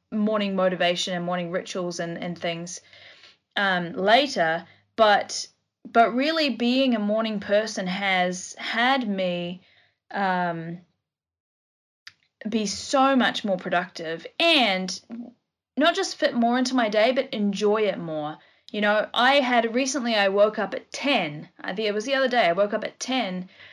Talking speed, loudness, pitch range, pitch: 150 wpm, -23 LUFS, 180-245 Hz, 210 Hz